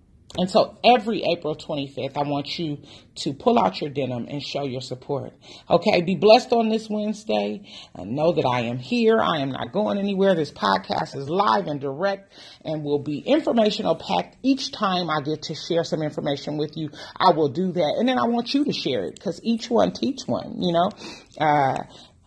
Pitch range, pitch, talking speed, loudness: 145-215 Hz, 170 Hz, 200 wpm, -23 LUFS